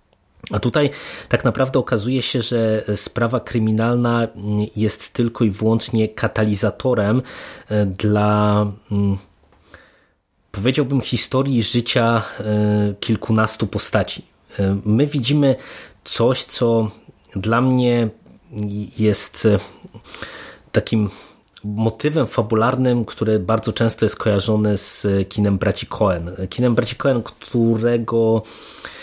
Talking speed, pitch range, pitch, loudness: 90 wpm, 105-120 Hz, 110 Hz, -19 LUFS